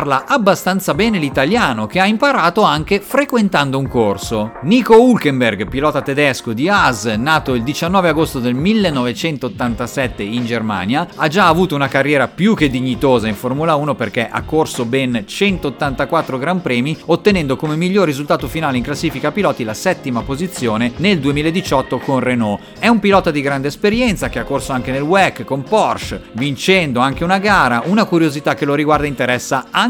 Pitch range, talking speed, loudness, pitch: 125-180 Hz, 165 wpm, -15 LUFS, 145 Hz